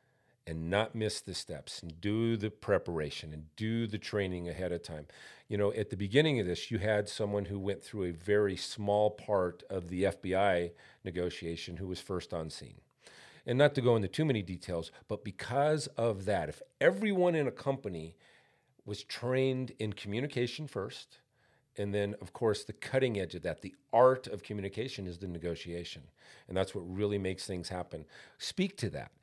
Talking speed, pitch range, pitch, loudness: 185 wpm, 90-115 Hz, 100 Hz, -34 LUFS